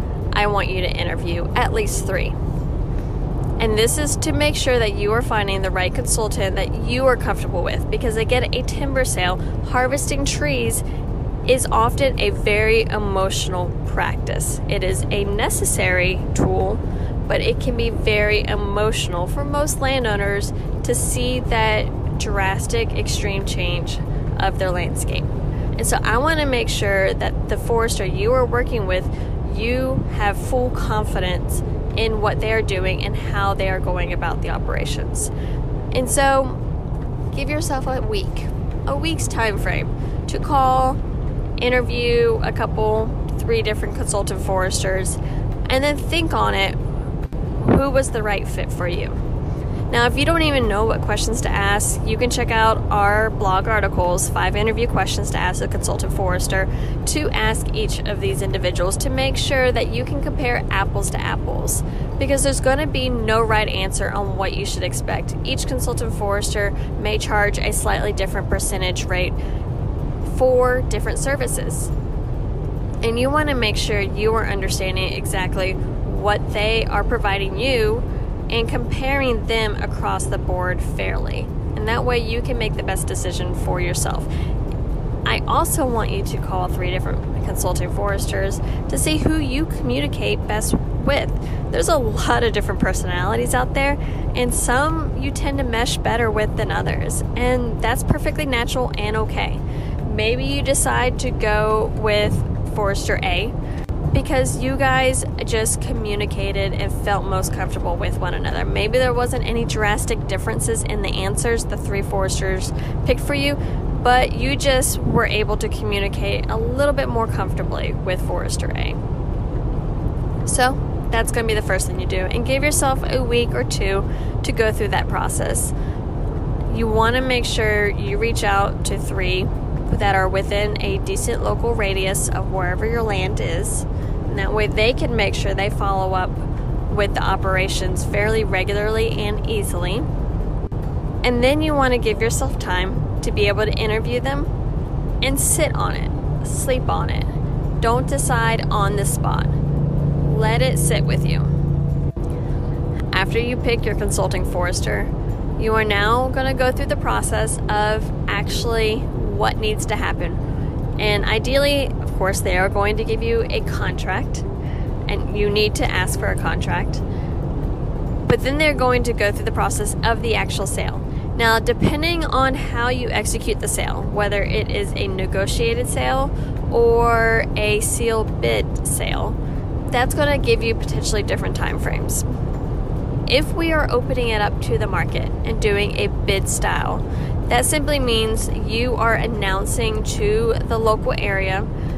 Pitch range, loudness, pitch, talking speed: 100-125 Hz, -20 LUFS, 110 Hz, 160 wpm